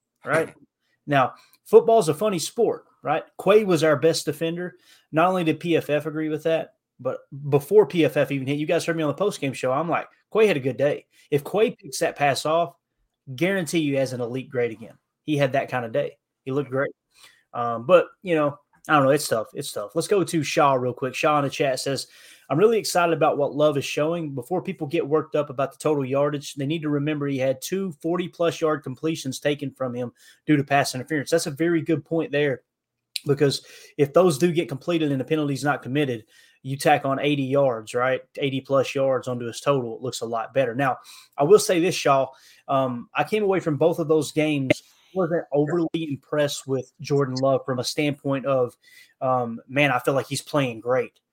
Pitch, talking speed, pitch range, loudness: 145 Hz, 215 wpm, 135-165 Hz, -23 LUFS